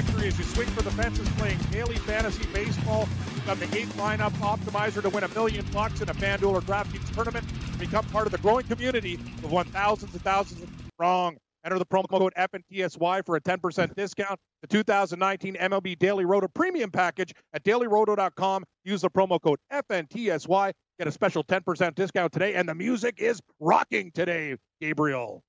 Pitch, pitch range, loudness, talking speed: 190 Hz, 175-200 Hz, -27 LUFS, 185 wpm